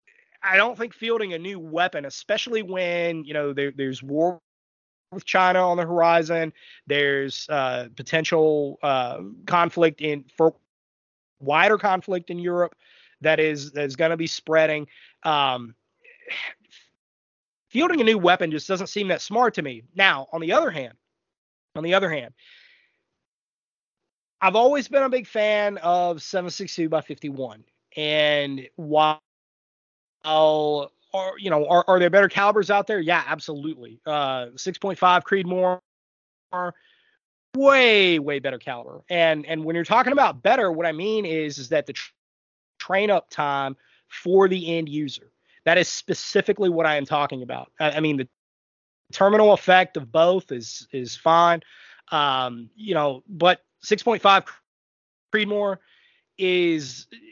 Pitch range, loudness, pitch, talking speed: 145-195 Hz, -22 LUFS, 170 Hz, 150 wpm